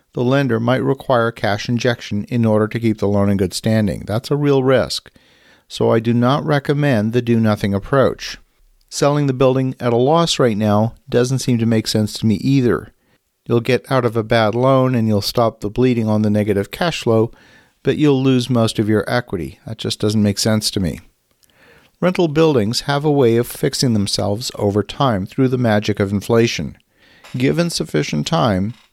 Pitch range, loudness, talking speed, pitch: 105-130 Hz, -17 LUFS, 195 wpm, 120 Hz